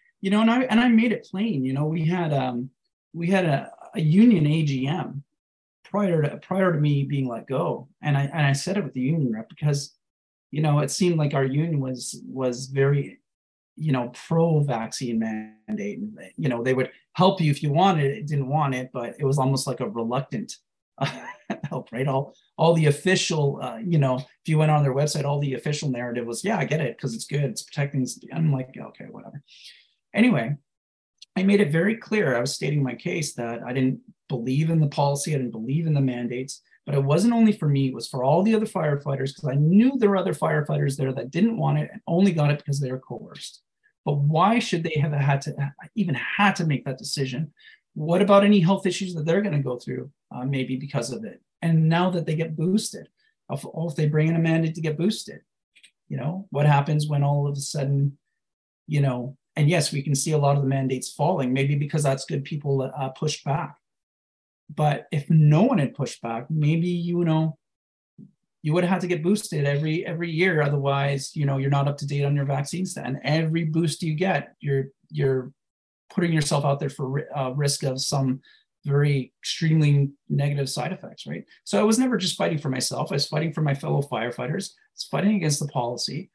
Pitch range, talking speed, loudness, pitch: 135-170 Hz, 220 wpm, -24 LUFS, 145 Hz